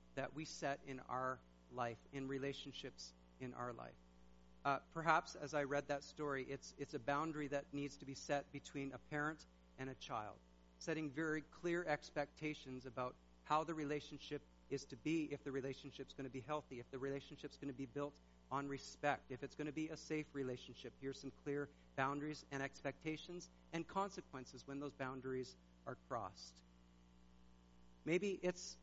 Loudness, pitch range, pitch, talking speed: -46 LUFS, 125-150 Hz, 140 Hz, 175 wpm